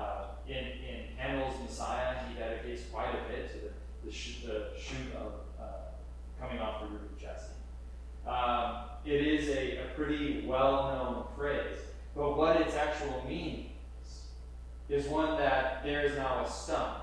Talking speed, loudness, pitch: 155 wpm, -35 LUFS, 125 Hz